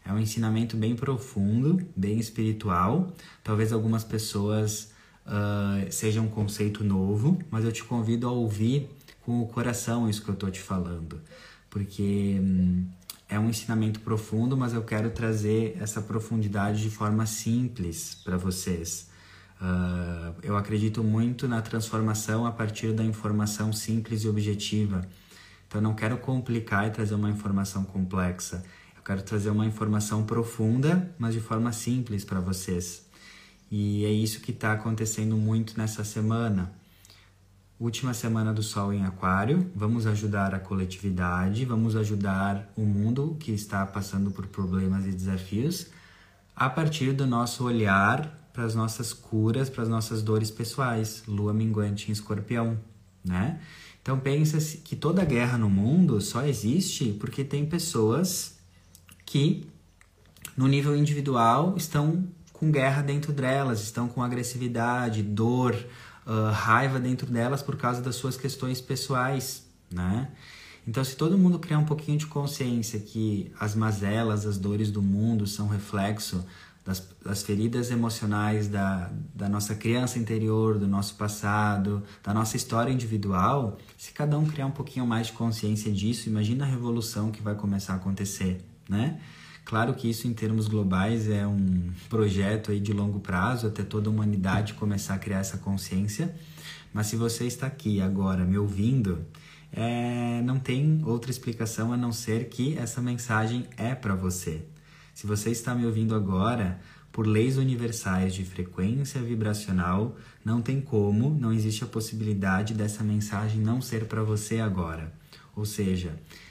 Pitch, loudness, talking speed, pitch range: 110 Hz, -28 LUFS, 150 wpm, 100-120 Hz